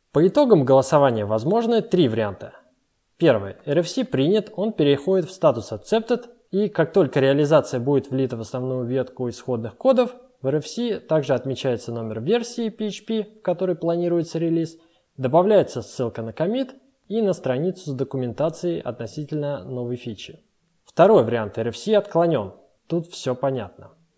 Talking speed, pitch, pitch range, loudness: 135 wpm, 160 Hz, 130-205 Hz, -22 LUFS